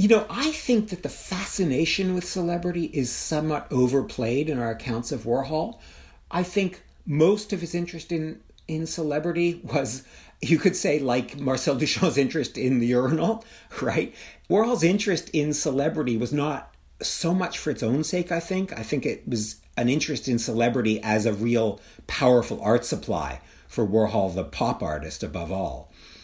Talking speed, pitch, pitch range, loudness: 165 wpm, 150 Hz, 120-175 Hz, -25 LUFS